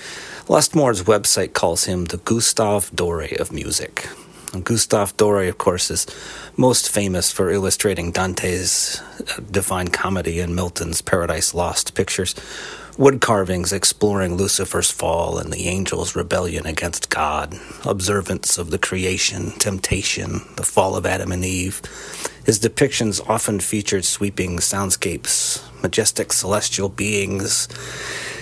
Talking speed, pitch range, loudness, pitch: 120 wpm, 90-105 Hz, -19 LUFS, 95 Hz